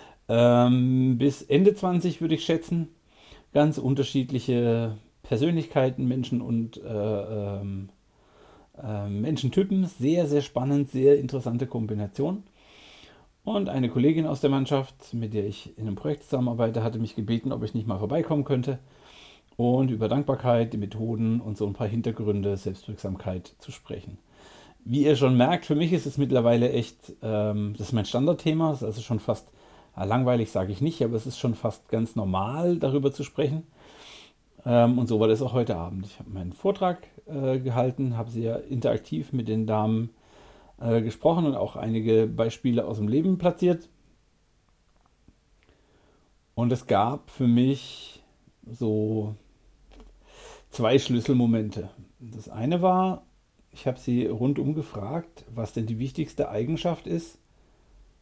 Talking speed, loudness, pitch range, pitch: 140 wpm, -26 LUFS, 110-145 Hz, 120 Hz